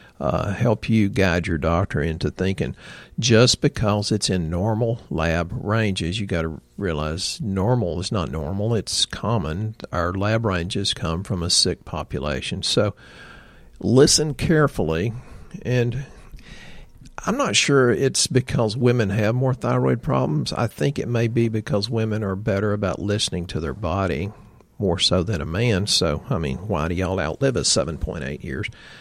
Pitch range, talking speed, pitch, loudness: 85-115 Hz, 155 wpm, 105 Hz, -22 LUFS